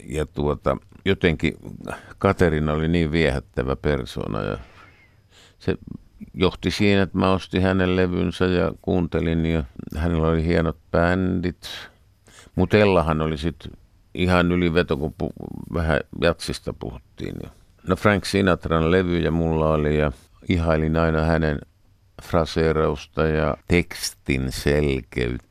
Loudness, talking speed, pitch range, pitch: -22 LUFS, 120 wpm, 80-95 Hz, 85 Hz